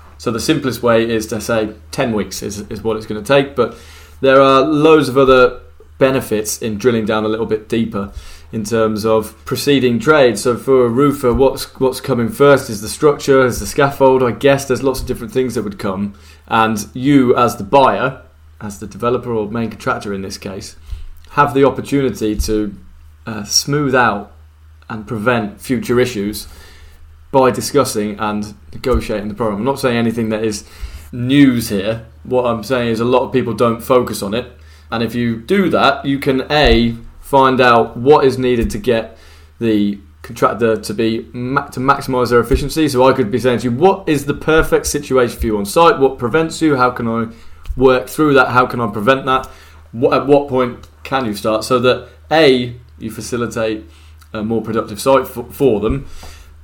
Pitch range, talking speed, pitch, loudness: 105-130 Hz, 190 wpm, 115 Hz, -15 LUFS